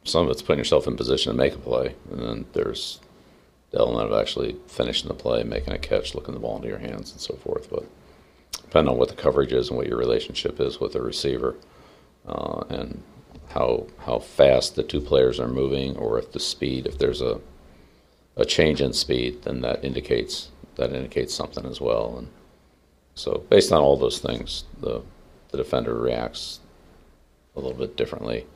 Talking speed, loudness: 195 wpm, -25 LUFS